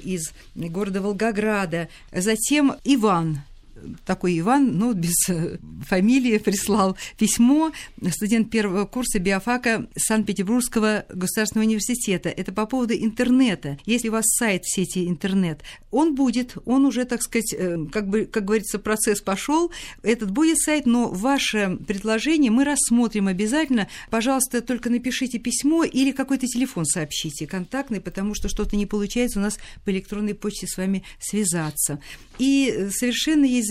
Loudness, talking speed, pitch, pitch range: -22 LUFS, 135 wpm, 215 Hz, 190-245 Hz